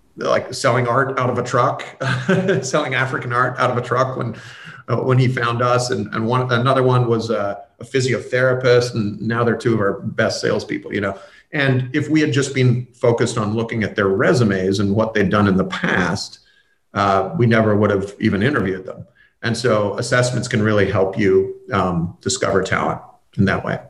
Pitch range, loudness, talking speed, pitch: 105-130 Hz, -18 LUFS, 200 wpm, 120 Hz